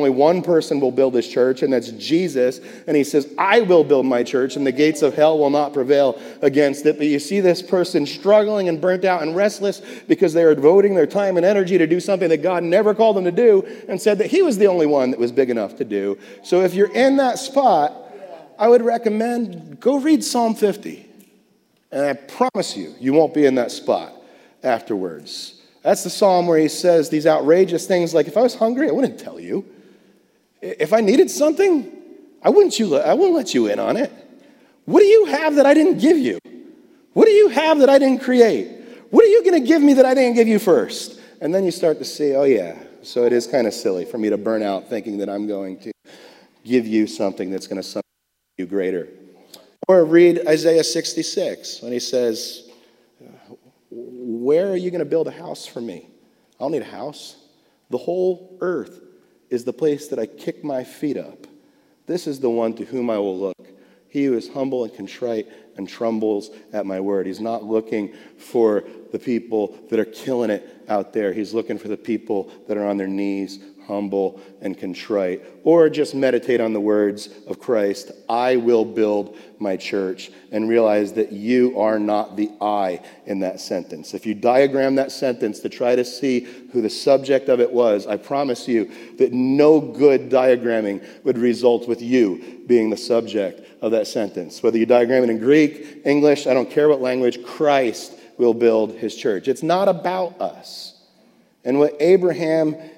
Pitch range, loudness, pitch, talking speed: 120-200 Hz, -18 LUFS, 150 Hz, 205 wpm